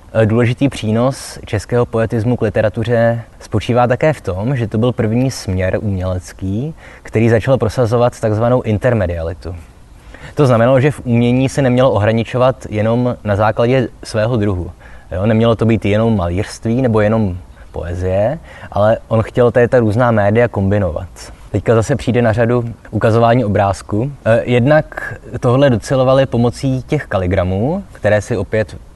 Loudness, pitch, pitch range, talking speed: -15 LUFS, 115 Hz, 105-125 Hz, 135 wpm